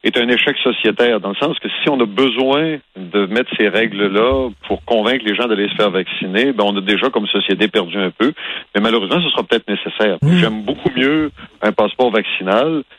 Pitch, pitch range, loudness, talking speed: 115 Hz, 105-135 Hz, -16 LUFS, 210 wpm